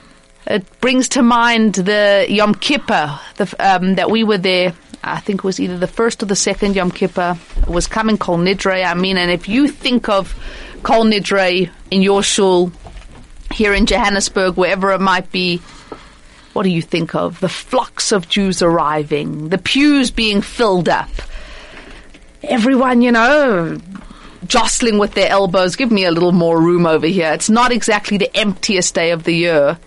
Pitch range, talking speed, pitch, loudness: 180-220 Hz, 175 wpm, 195 Hz, -14 LUFS